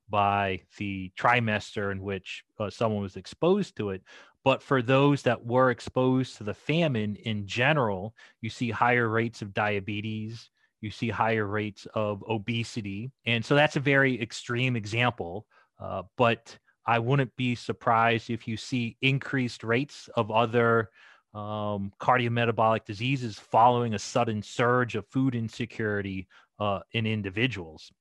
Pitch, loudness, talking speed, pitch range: 115 Hz, -27 LUFS, 145 wpm, 105-125 Hz